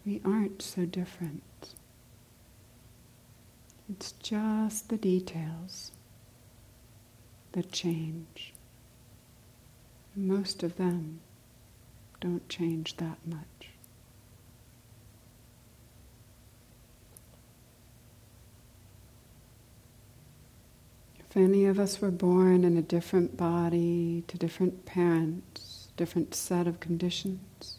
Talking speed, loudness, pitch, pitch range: 75 wpm, -30 LUFS, 160 Hz, 120-180 Hz